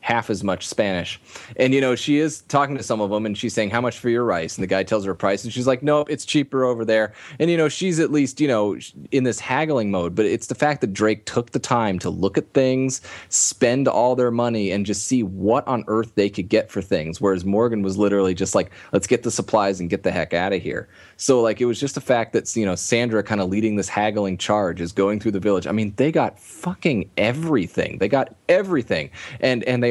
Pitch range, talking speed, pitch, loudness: 100-130 Hz, 255 wpm, 115 Hz, -21 LUFS